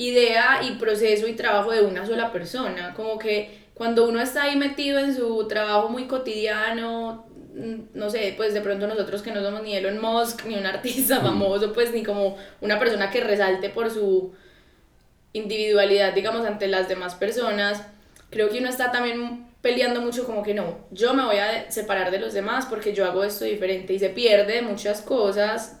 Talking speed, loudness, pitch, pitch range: 185 wpm, -23 LUFS, 215 Hz, 200-230 Hz